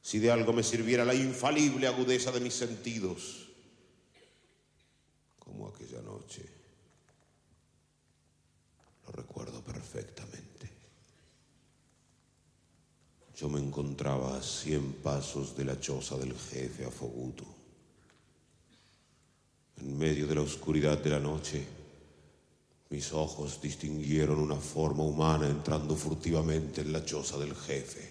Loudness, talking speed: -33 LUFS, 105 wpm